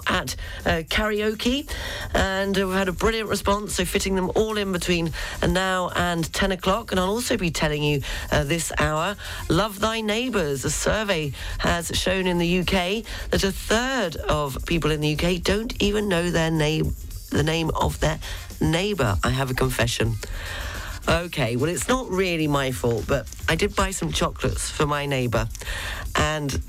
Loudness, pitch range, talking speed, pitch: -24 LUFS, 135-195 Hz, 175 wpm, 170 Hz